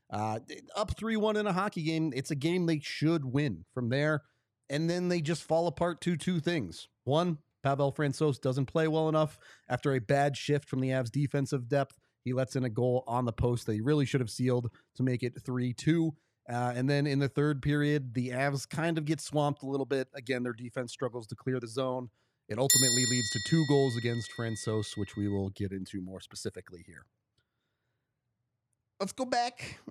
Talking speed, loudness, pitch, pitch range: 205 wpm, -31 LUFS, 135 Hz, 120-150 Hz